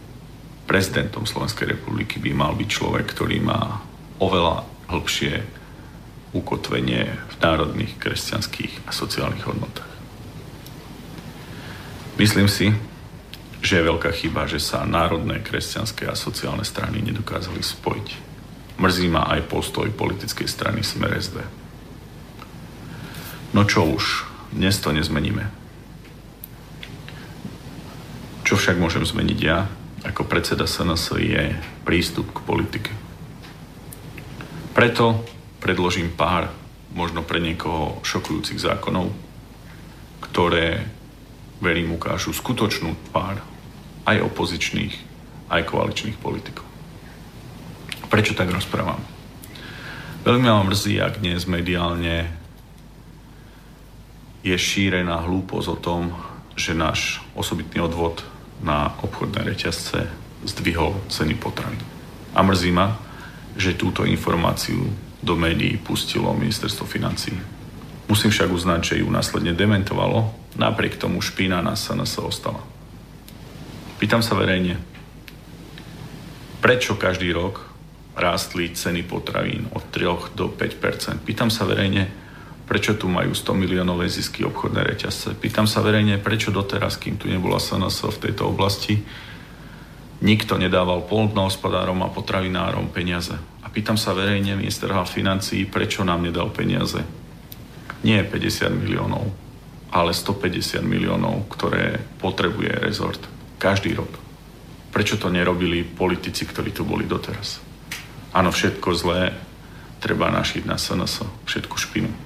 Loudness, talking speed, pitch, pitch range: -22 LUFS, 110 wpm, 100 Hz, 90-110 Hz